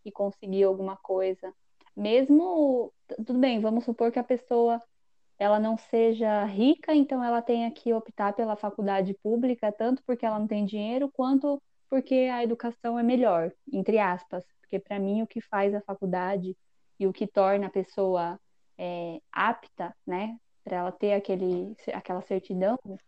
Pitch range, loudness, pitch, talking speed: 195-235 Hz, -28 LUFS, 215 Hz, 160 wpm